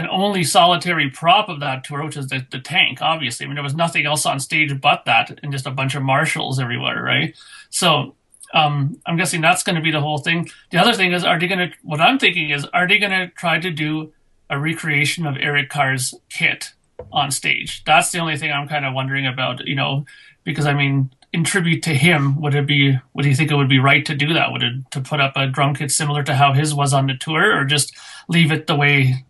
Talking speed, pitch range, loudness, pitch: 250 wpm, 140-165 Hz, -17 LUFS, 145 Hz